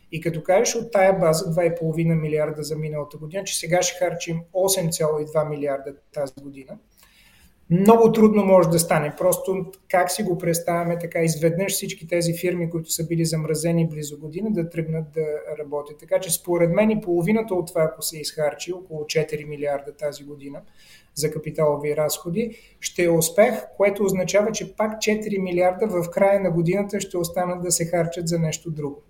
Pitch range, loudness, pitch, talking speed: 155-185 Hz, -22 LUFS, 170 Hz, 175 wpm